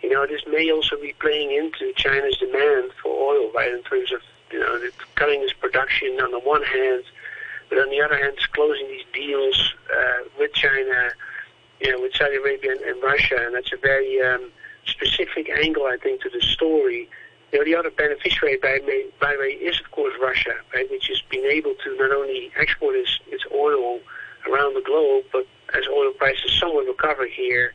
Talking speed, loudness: 200 wpm, -21 LUFS